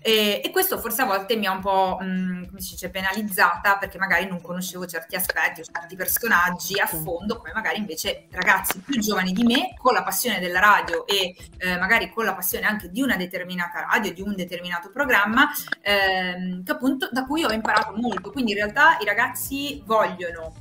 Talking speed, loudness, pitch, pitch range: 200 wpm, -22 LUFS, 195 Hz, 180-230 Hz